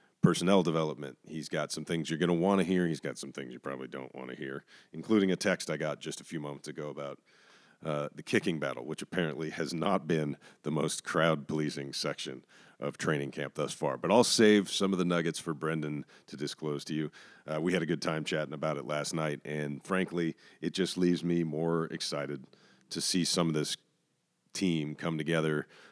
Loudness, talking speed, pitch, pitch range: -32 LUFS, 210 wpm, 80 Hz, 75-85 Hz